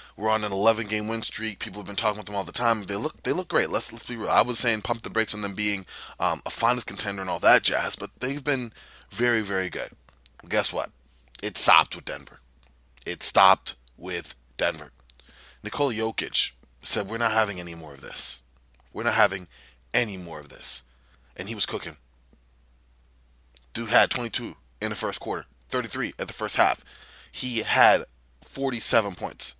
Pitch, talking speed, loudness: 100 Hz, 195 wpm, -25 LUFS